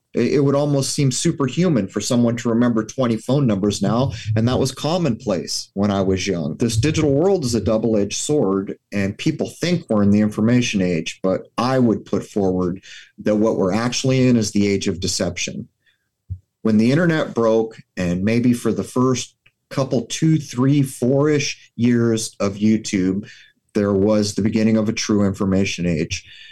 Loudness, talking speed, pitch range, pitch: -19 LUFS, 175 wpm, 100-130 Hz, 110 Hz